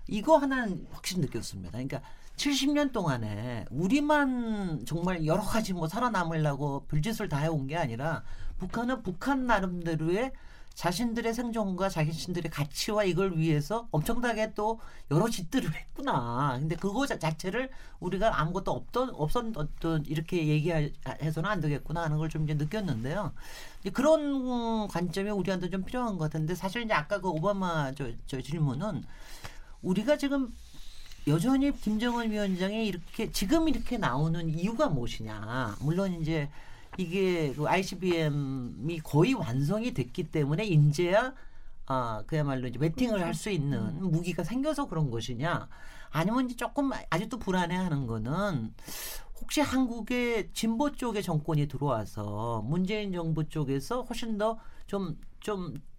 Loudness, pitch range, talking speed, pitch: -31 LUFS, 150-220 Hz, 315 characters per minute, 175 Hz